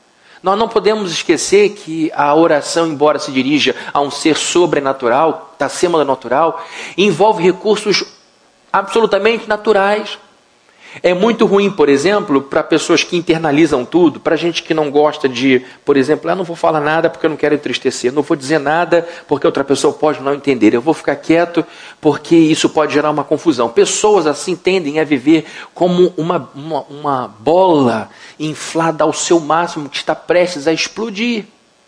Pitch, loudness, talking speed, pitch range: 165 Hz, -14 LUFS, 165 wpm, 150-195 Hz